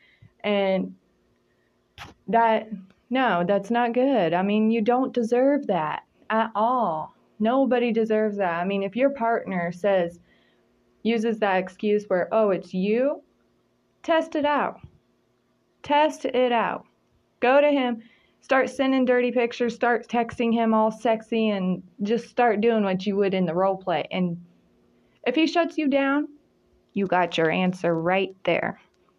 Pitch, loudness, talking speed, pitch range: 225 Hz, -23 LUFS, 145 wpm, 190-250 Hz